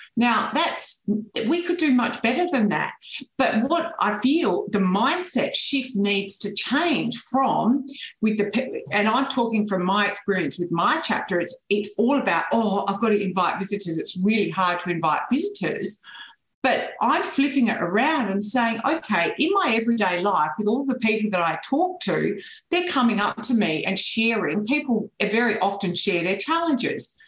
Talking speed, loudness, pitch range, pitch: 175 wpm, -22 LUFS, 200-270 Hz, 225 Hz